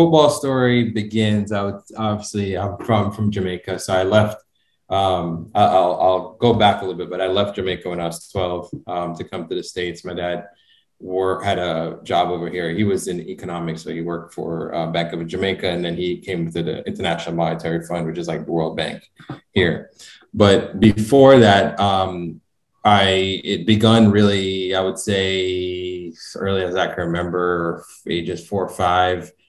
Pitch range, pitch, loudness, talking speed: 85-100 Hz, 95 Hz, -19 LUFS, 185 wpm